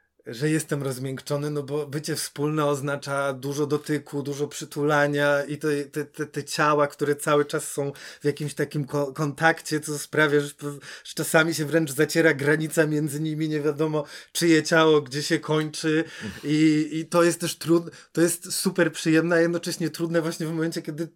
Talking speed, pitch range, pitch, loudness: 165 wpm, 145-160 Hz, 150 Hz, -24 LUFS